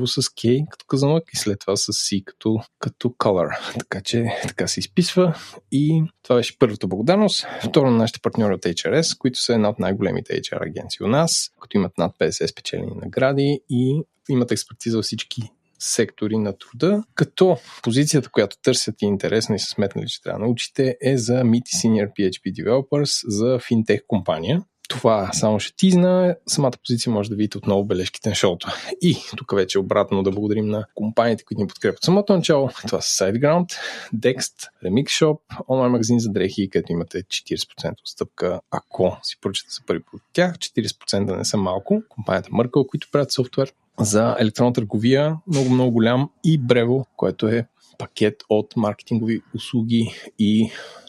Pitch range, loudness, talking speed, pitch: 110-145 Hz, -21 LUFS, 175 wpm, 120 Hz